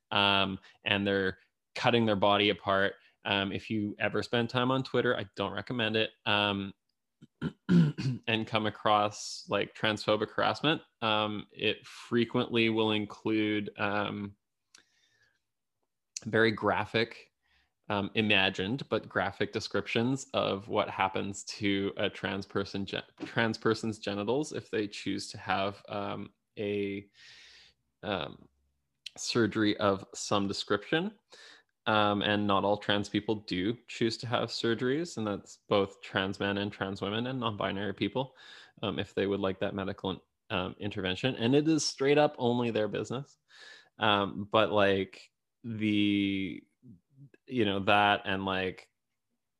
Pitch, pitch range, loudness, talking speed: 105 Hz, 100-115 Hz, -31 LUFS, 135 wpm